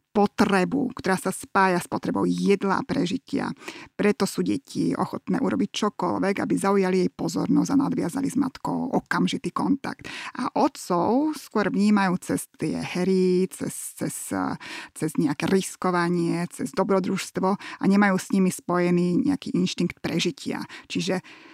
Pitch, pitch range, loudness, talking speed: 195 Hz, 180-225 Hz, -25 LUFS, 135 wpm